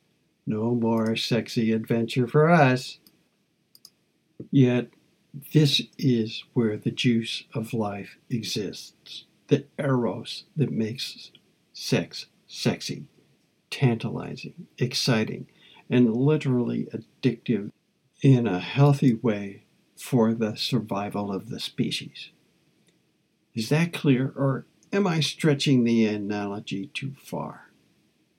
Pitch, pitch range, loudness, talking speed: 120 Hz, 110-140 Hz, -25 LUFS, 100 wpm